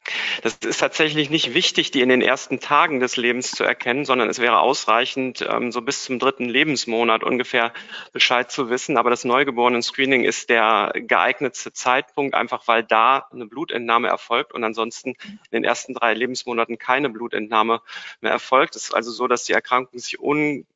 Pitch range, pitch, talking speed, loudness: 115-135 Hz, 125 Hz, 175 wpm, -20 LUFS